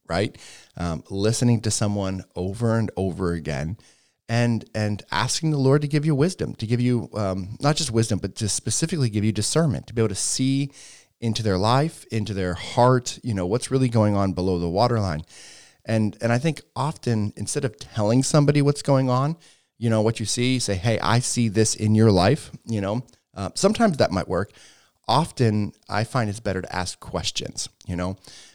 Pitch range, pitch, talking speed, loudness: 100-130 Hz, 115 Hz, 200 wpm, -23 LUFS